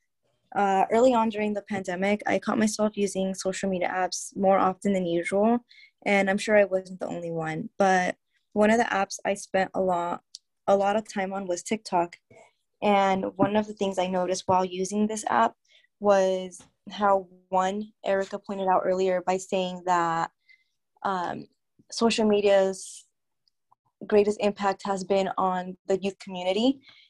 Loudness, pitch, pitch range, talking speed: -26 LUFS, 195 Hz, 185-210 Hz, 160 wpm